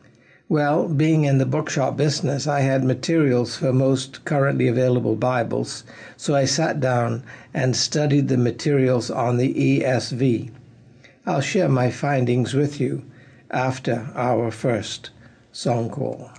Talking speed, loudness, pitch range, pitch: 130 wpm, -21 LUFS, 125-140 Hz, 130 Hz